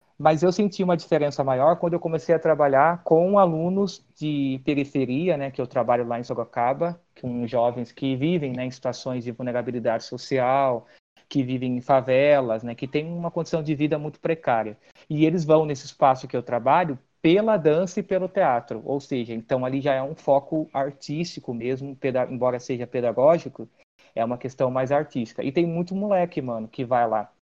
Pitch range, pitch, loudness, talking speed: 125-160 Hz, 140 Hz, -24 LUFS, 185 wpm